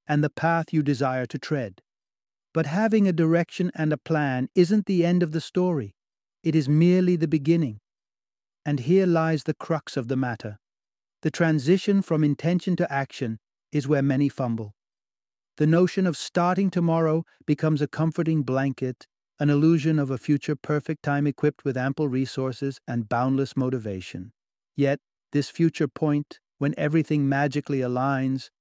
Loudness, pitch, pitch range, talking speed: -24 LUFS, 150 Hz, 130-165 Hz, 155 wpm